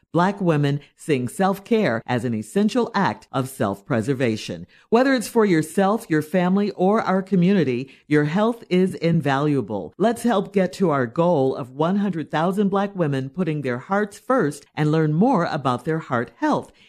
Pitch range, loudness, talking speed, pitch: 135-200 Hz, -21 LUFS, 165 wpm, 165 Hz